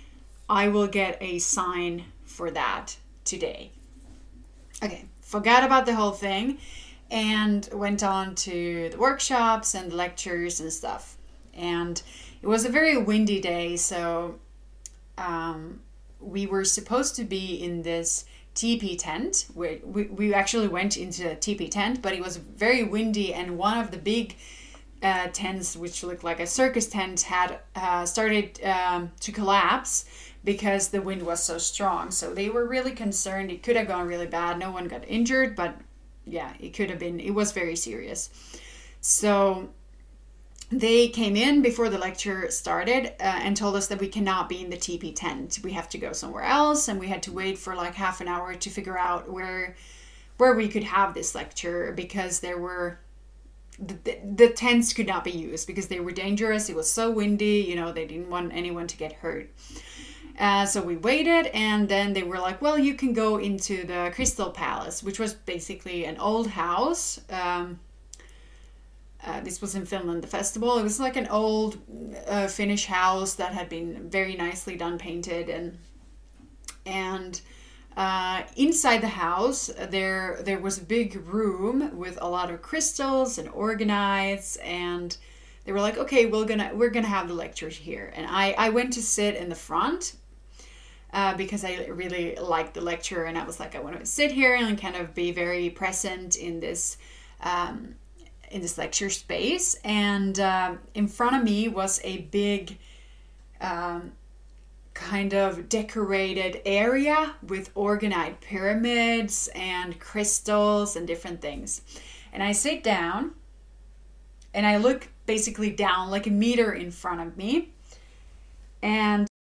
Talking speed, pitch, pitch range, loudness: 170 wpm, 195 Hz, 175-215 Hz, -26 LUFS